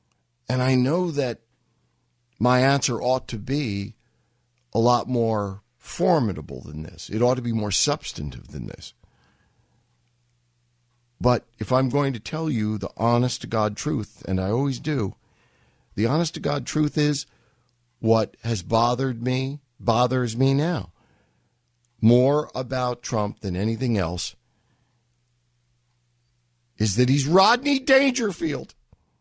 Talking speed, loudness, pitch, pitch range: 130 wpm, -23 LUFS, 120 Hz, 110-130 Hz